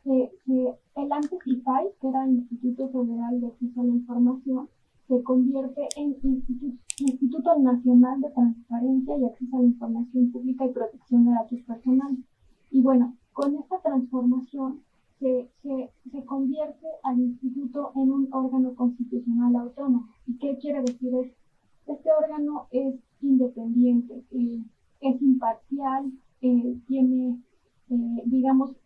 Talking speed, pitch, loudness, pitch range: 135 wpm, 255 Hz, -25 LUFS, 245-270 Hz